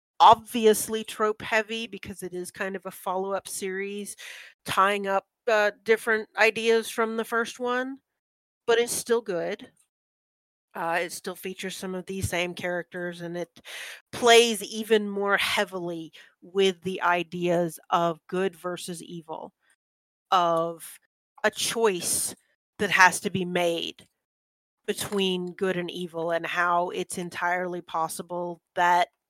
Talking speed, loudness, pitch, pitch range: 135 wpm, -26 LUFS, 185 Hz, 175-215 Hz